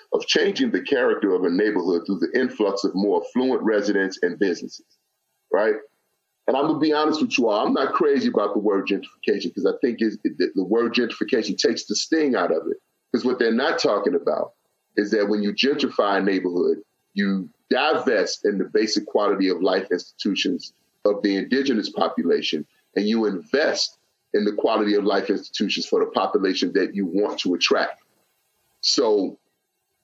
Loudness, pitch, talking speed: -22 LUFS, 115 Hz, 180 wpm